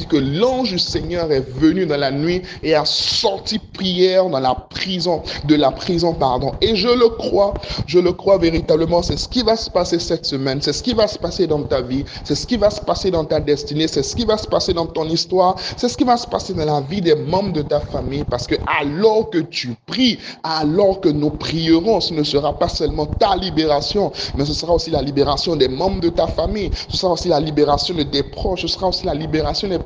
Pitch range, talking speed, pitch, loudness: 145-185 Hz, 235 wpm, 165 Hz, -18 LUFS